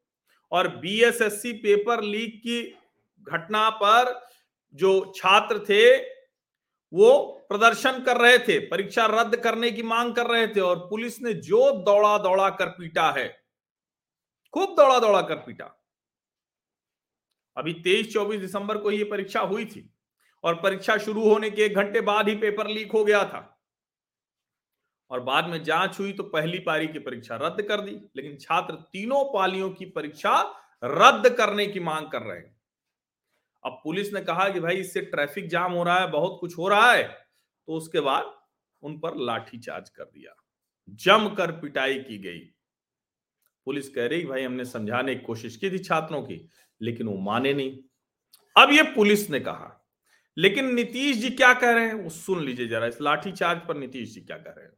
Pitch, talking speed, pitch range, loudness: 195 Hz, 175 wpm, 160-225 Hz, -23 LUFS